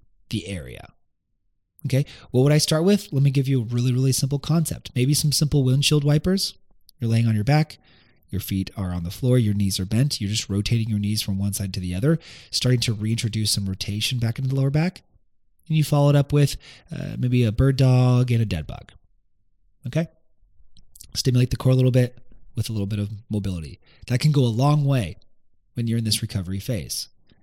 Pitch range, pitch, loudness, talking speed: 100-135 Hz, 120 Hz, -22 LUFS, 215 wpm